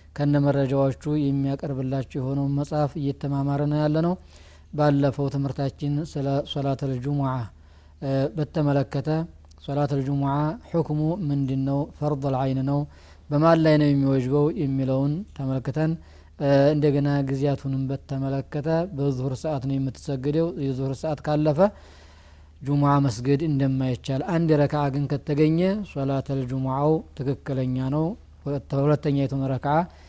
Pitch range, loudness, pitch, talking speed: 135-150 Hz, -24 LUFS, 140 Hz, 100 wpm